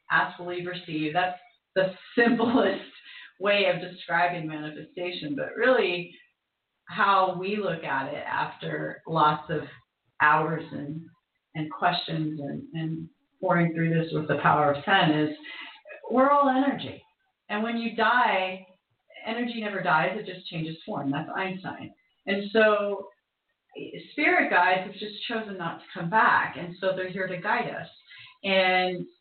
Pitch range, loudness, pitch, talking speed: 160-210 Hz, -26 LUFS, 185 Hz, 145 wpm